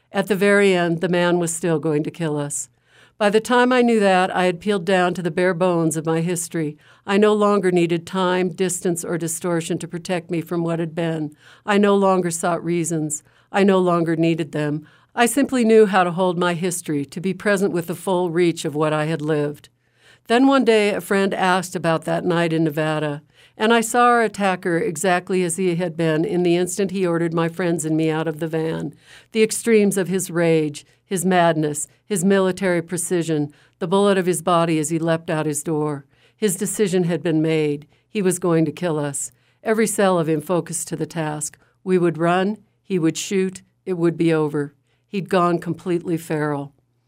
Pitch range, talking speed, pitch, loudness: 160-190 Hz, 205 wpm, 175 Hz, -20 LUFS